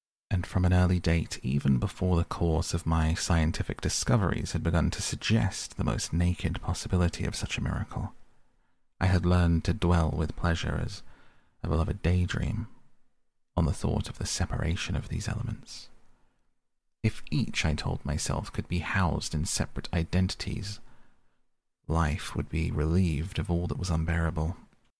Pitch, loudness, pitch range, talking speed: 85 Hz, -29 LUFS, 80-95 Hz, 165 wpm